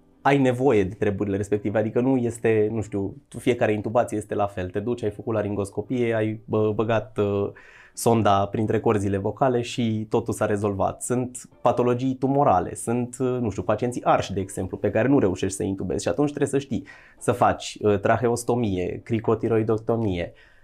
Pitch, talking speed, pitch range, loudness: 110 Hz, 160 wpm, 105-120 Hz, -24 LUFS